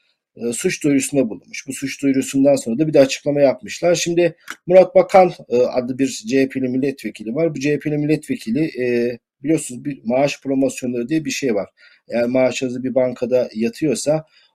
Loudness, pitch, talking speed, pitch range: -18 LUFS, 135 Hz, 150 wpm, 125-160 Hz